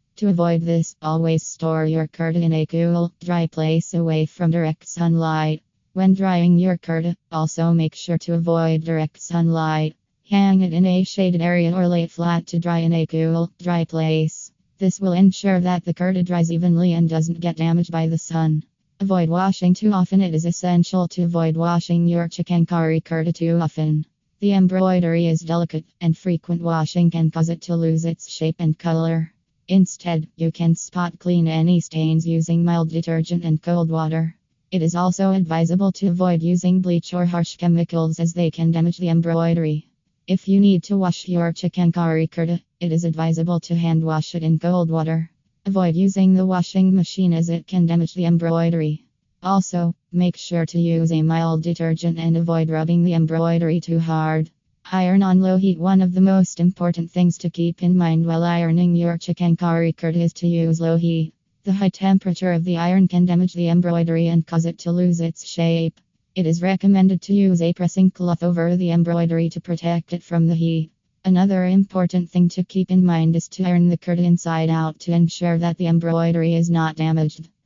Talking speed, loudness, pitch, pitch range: 190 wpm, -19 LUFS, 170 Hz, 165-180 Hz